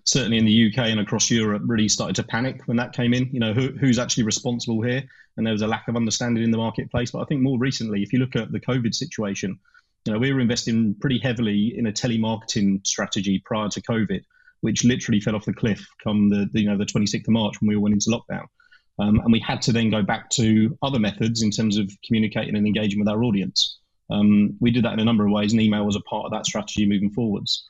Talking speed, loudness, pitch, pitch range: 255 wpm, -22 LUFS, 110 Hz, 105-120 Hz